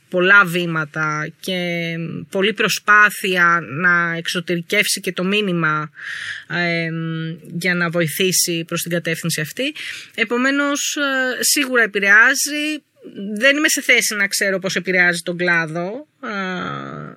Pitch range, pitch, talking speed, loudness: 170-210 Hz, 180 Hz, 110 wpm, -17 LUFS